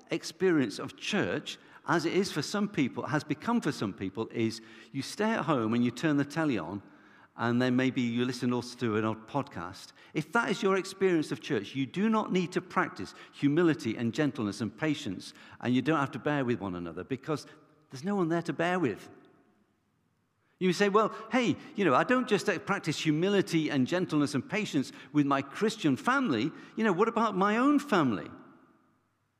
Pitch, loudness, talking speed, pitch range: 155 Hz, -30 LUFS, 195 wpm, 125-190 Hz